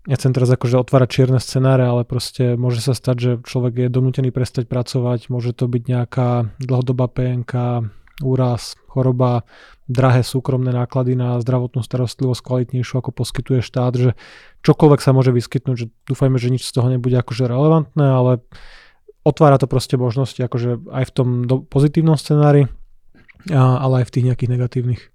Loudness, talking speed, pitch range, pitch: -18 LUFS, 160 wpm, 125-130 Hz, 125 Hz